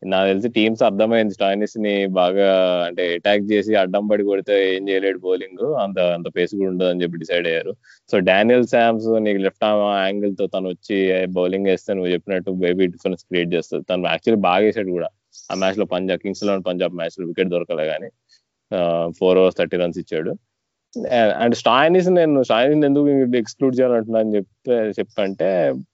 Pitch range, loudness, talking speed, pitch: 90-105 Hz, -19 LUFS, 170 wpm, 95 Hz